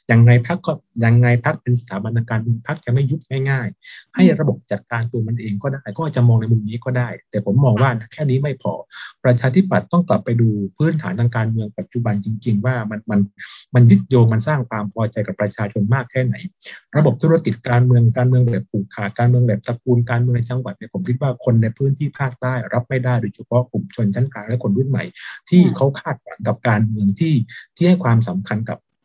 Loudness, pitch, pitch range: -18 LUFS, 120 Hz, 110-130 Hz